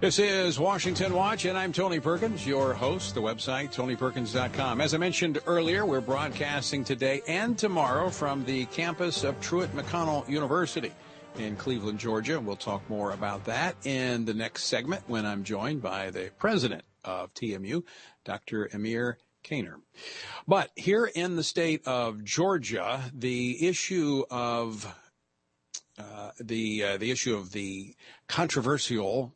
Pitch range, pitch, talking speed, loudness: 115-170 Hz, 135 Hz, 145 wpm, -29 LUFS